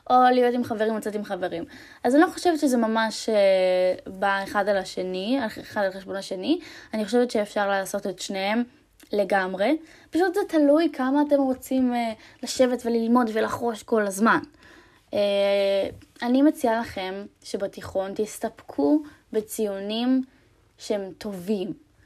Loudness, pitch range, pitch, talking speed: -24 LUFS, 200-270 Hz, 225 Hz, 130 wpm